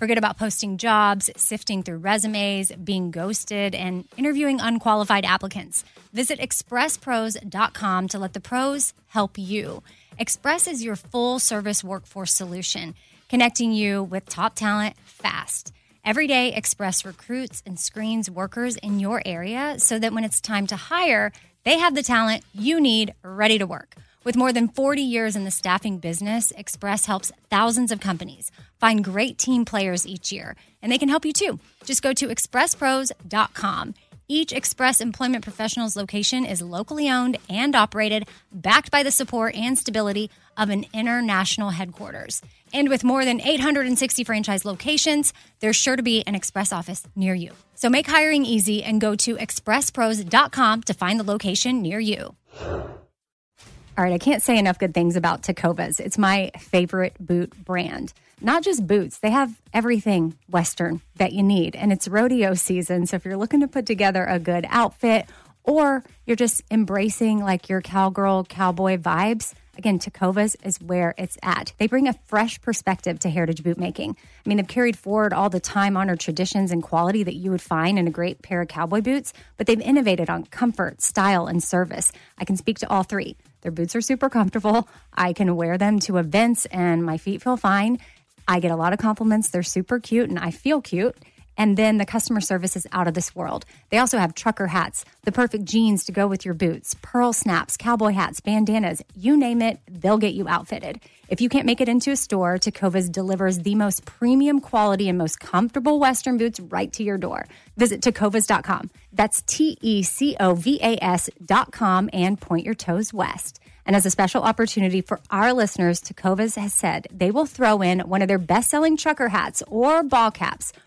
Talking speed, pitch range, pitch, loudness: 180 wpm, 190-235 Hz, 210 Hz, -22 LUFS